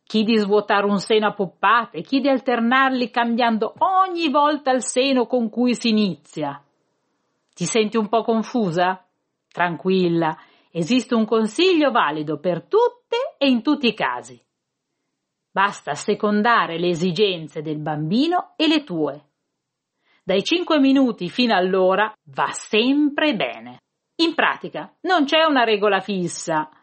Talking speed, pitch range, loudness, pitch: 135 wpm, 175-260 Hz, -20 LUFS, 220 Hz